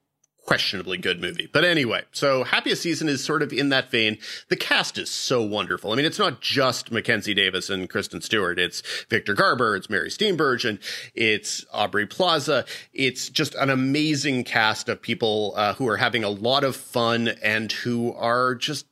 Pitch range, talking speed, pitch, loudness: 110-140 Hz, 185 wpm, 125 Hz, -23 LUFS